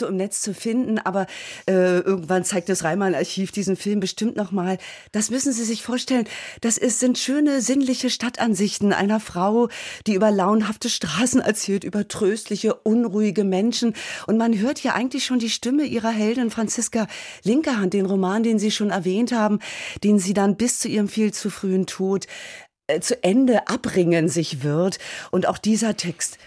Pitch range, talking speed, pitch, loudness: 195-235 Hz, 175 wpm, 215 Hz, -22 LUFS